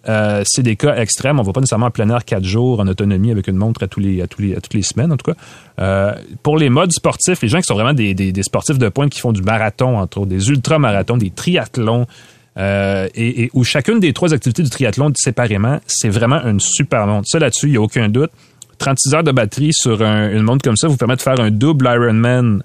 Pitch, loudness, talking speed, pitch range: 120 Hz, -15 LUFS, 260 wpm, 105-140 Hz